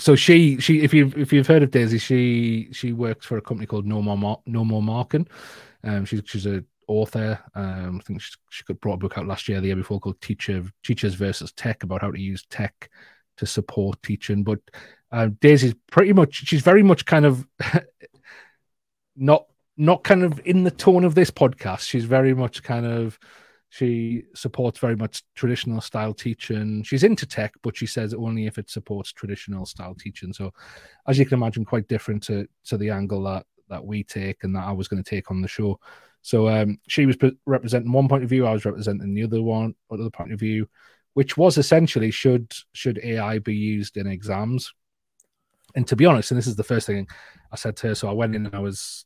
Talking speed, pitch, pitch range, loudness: 215 wpm, 110 Hz, 105-130 Hz, -22 LUFS